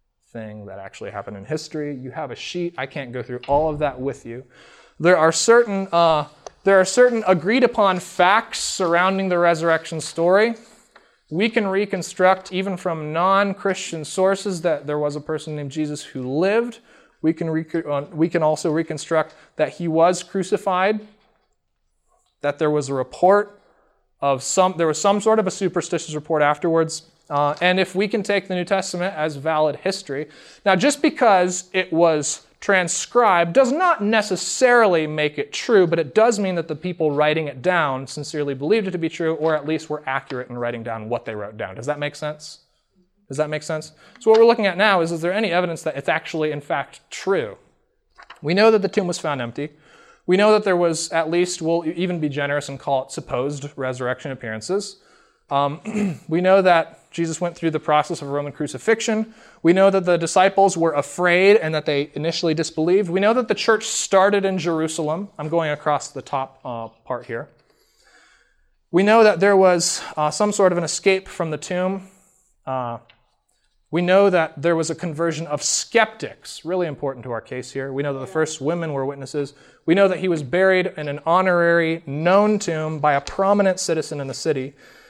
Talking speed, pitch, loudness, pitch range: 190 wpm, 165 Hz, -20 LUFS, 150-190 Hz